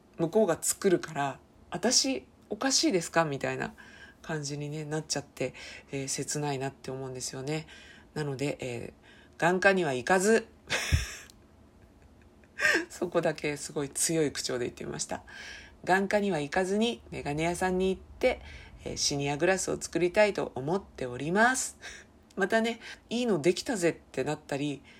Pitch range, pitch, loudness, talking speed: 145-195 Hz, 165 Hz, -30 LUFS, 310 characters per minute